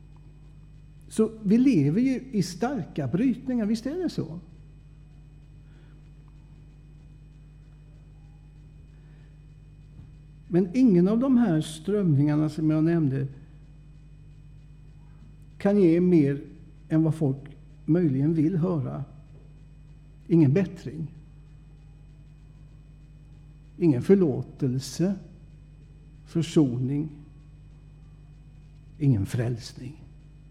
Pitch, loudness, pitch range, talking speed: 150 Hz, -25 LUFS, 145-155 Hz, 70 wpm